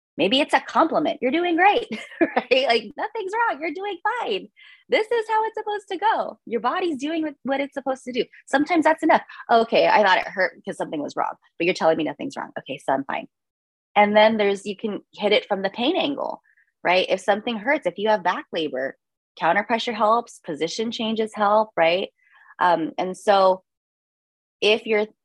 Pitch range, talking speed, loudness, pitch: 205-330 Hz, 195 wpm, -22 LUFS, 240 Hz